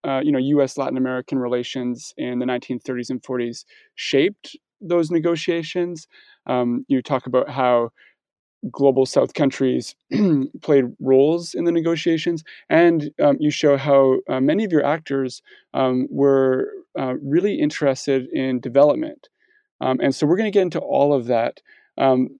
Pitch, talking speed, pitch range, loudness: 140 Hz, 155 wpm, 130-170 Hz, -20 LUFS